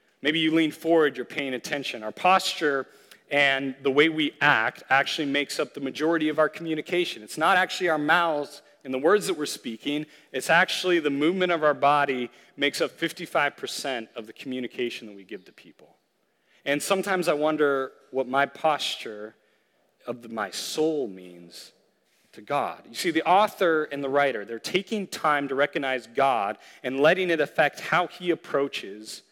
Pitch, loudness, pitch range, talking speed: 145 Hz, -25 LUFS, 130-165 Hz, 175 wpm